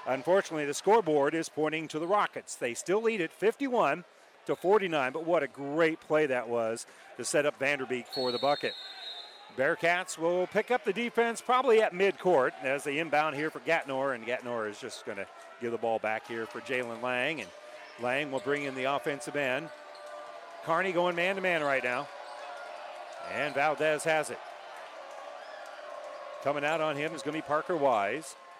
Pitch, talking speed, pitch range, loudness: 150 Hz, 185 wpm, 125-165 Hz, -30 LUFS